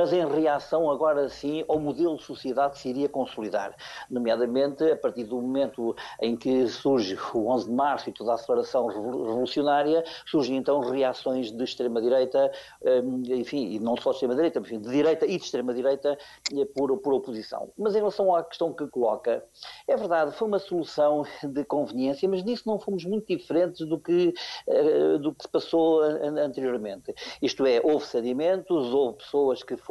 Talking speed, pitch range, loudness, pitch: 170 wpm, 130-175 Hz, -26 LUFS, 145 Hz